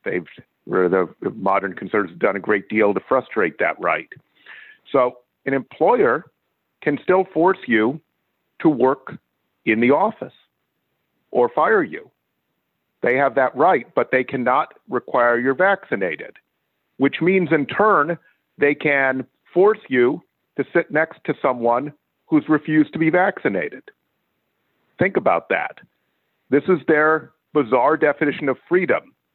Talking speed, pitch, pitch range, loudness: 135 wpm, 155 Hz, 135-185 Hz, -19 LUFS